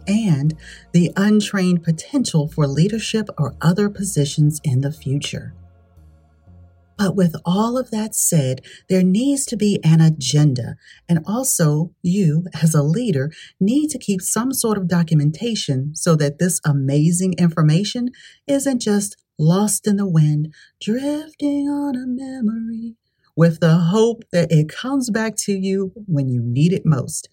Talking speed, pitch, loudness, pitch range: 145 wpm, 175 Hz, -19 LUFS, 150-220 Hz